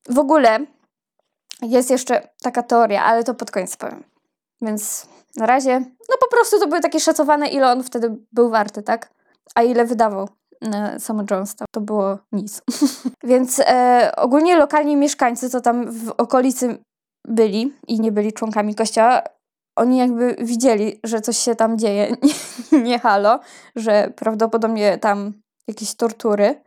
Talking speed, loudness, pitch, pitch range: 150 wpm, -18 LUFS, 235 Hz, 220-260 Hz